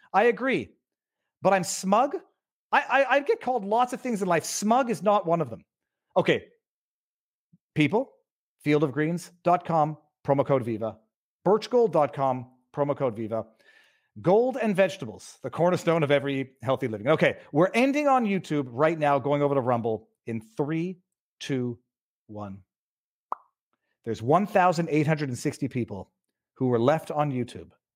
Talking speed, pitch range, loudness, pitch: 135 wpm, 130-195 Hz, -26 LUFS, 150 Hz